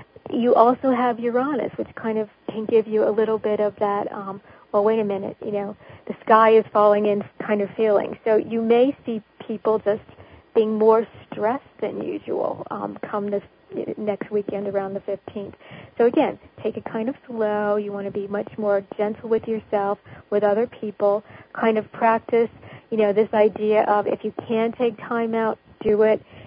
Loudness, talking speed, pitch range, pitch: -22 LUFS, 190 wpm, 205-225 Hz, 215 Hz